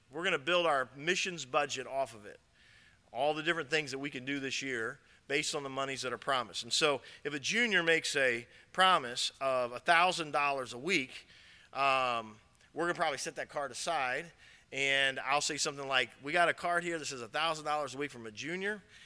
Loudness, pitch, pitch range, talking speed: -32 LUFS, 140 Hz, 130-165 Hz, 200 wpm